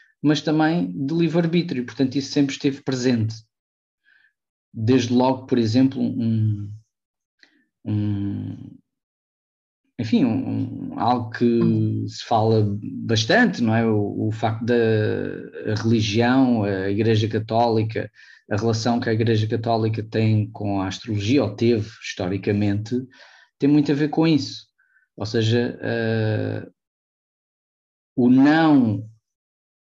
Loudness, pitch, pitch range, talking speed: -21 LUFS, 115 Hz, 105-125 Hz, 115 wpm